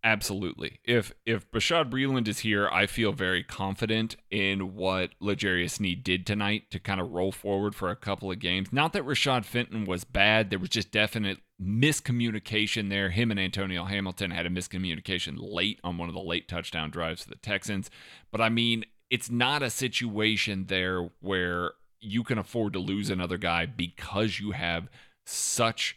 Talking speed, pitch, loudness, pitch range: 180 wpm, 100 Hz, -28 LUFS, 90-110 Hz